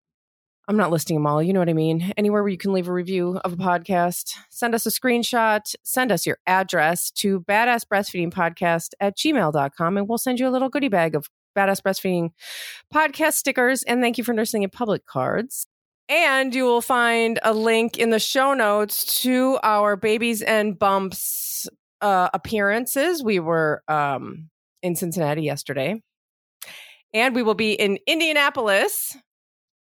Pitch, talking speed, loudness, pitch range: 205 Hz, 165 wpm, -21 LUFS, 180-240 Hz